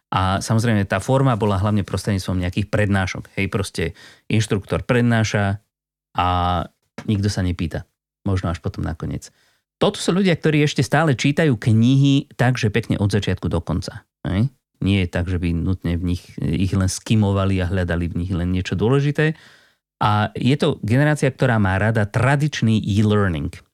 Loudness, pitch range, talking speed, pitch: -20 LUFS, 95-120 Hz, 160 wpm, 105 Hz